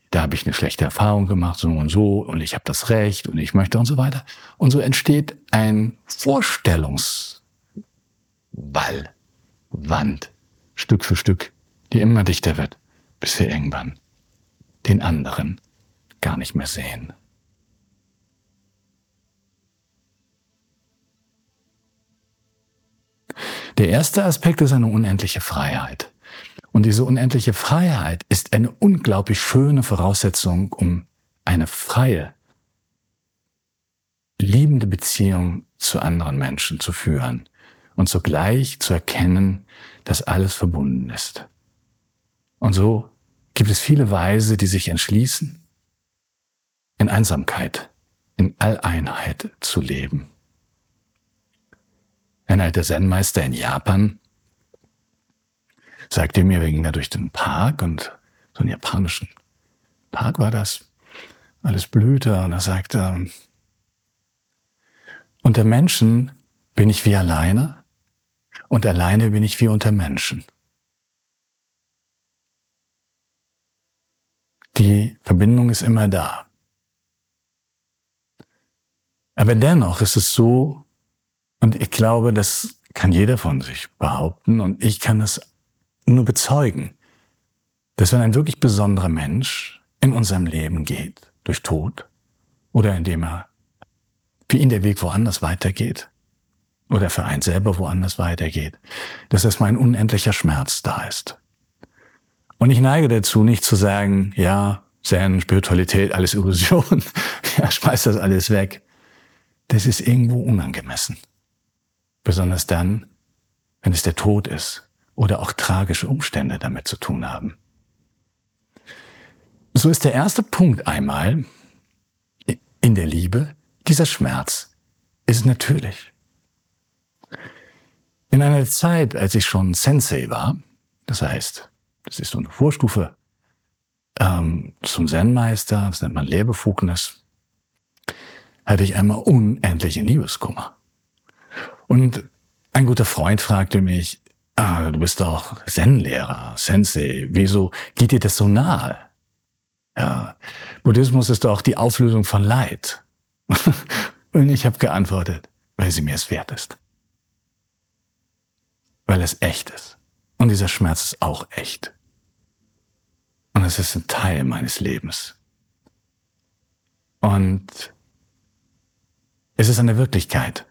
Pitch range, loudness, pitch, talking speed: 90-115 Hz, -19 LUFS, 105 Hz, 115 wpm